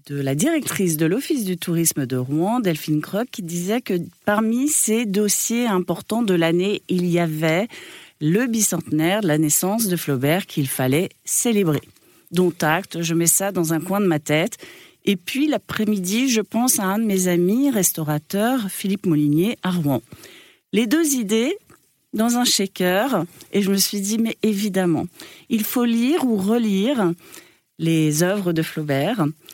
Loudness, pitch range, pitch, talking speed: -20 LUFS, 165-225 Hz, 195 Hz, 165 wpm